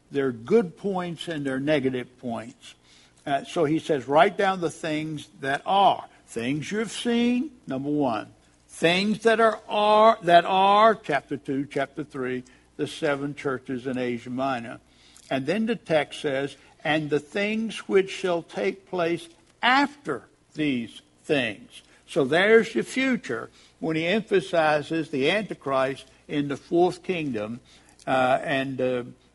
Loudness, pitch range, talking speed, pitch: -25 LUFS, 130-195 Hz, 140 wpm, 155 Hz